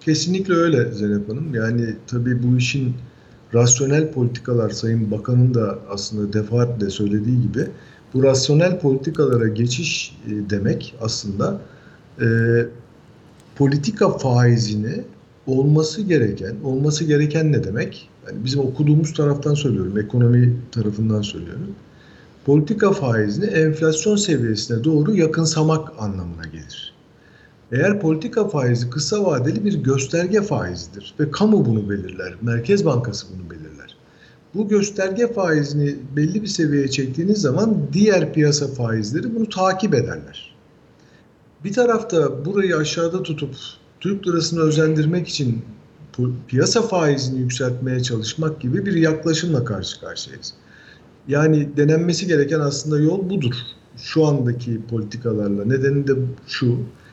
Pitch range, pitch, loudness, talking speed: 115-160 Hz, 140 Hz, -20 LUFS, 115 wpm